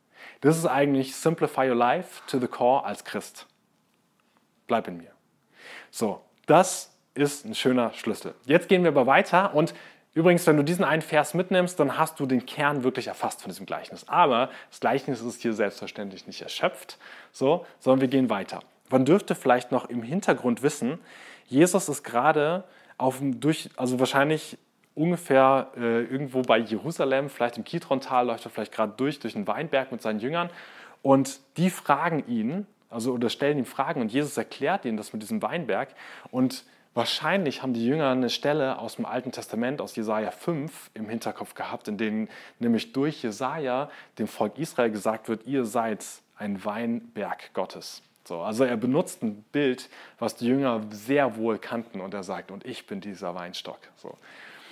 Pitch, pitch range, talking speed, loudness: 135 Hz, 120-160 Hz, 175 wpm, -26 LUFS